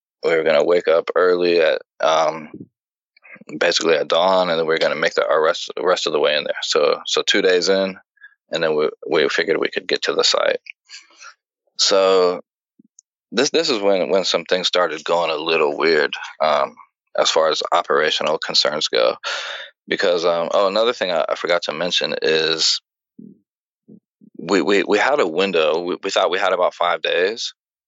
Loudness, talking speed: -18 LUFS, 185 wpm